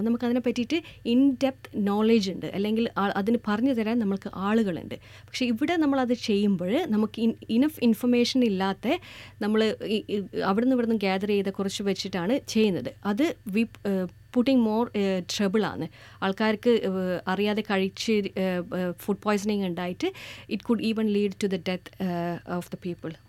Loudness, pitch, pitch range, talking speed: -26 LUFS, 210 Hz, 195-235 Hz, 135 wpm